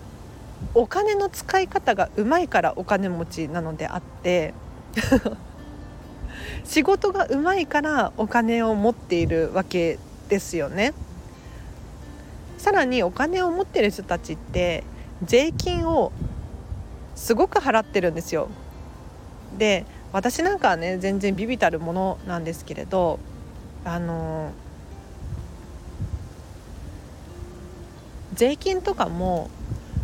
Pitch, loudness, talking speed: 180 Hz, -23 LUFS, 220 characters per minute